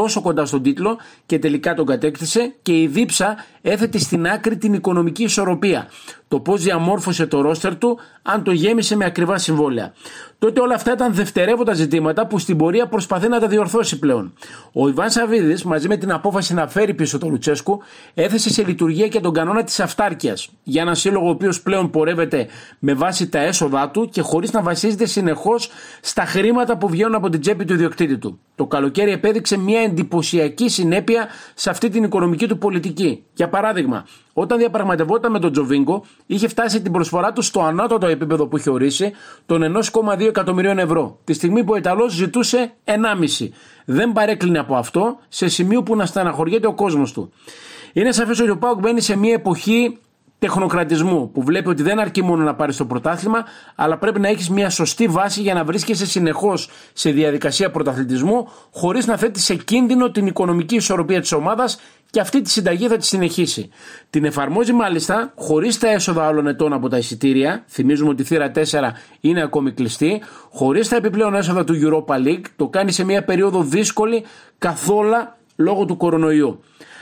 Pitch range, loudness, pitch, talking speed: 160-220 Hz, -18 LUFS, 190 Hz, 180 wpm